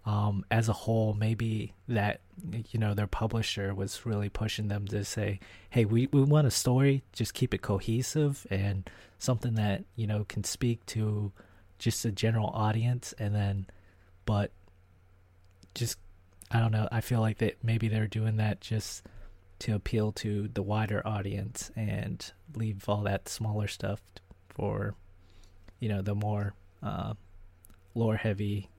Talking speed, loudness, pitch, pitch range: 155 wpm, -31 LUFS, 105 Hz, 95-110 Hz